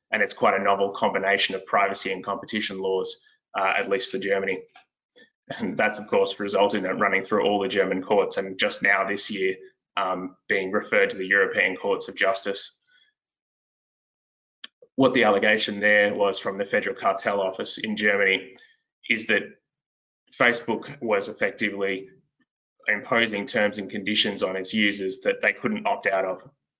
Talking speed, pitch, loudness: 165 wpm, 110 Hz, -24 LUFS